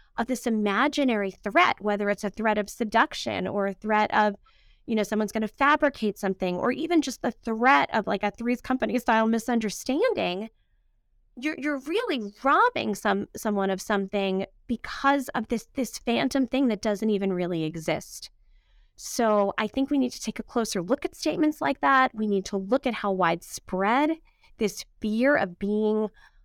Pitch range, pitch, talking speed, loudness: 200-260 Hz, 220 Hz, 170 wpm, -26 LUFS